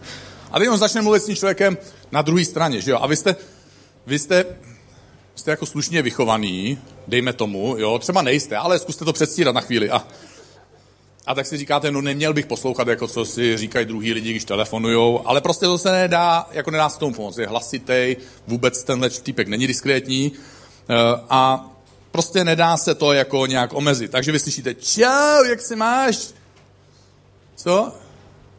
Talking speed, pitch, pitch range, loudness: 175 wpm, 135 Hz, 120-165 Hz, -19 LUFS